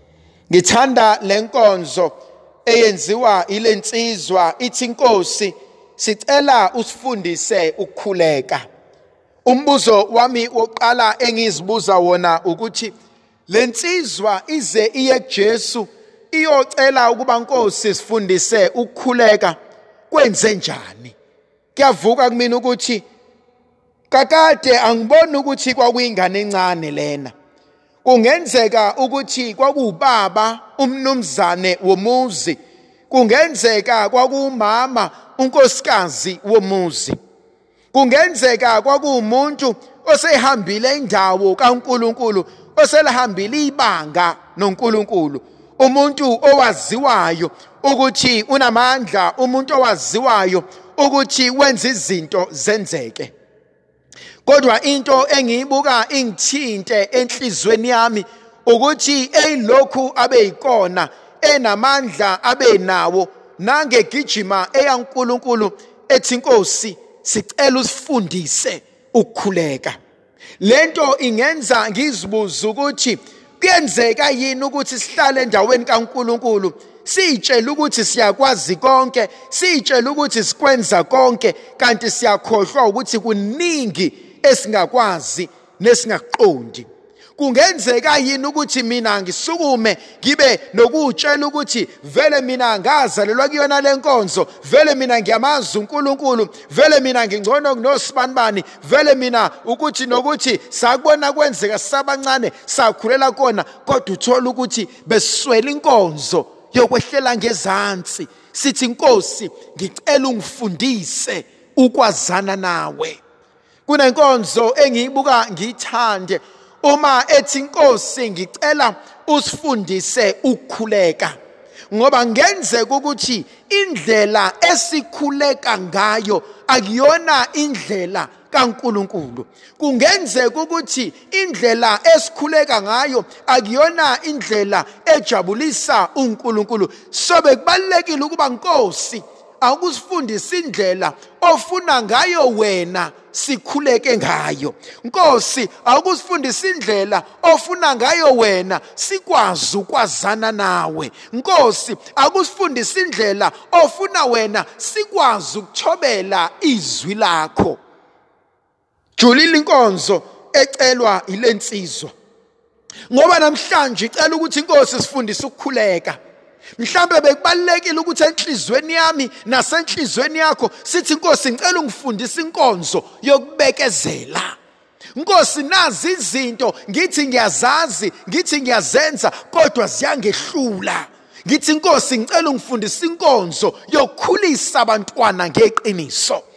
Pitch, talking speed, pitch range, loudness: 255 Hz, 80 wpm, 220-295 Hz, -15 LUFS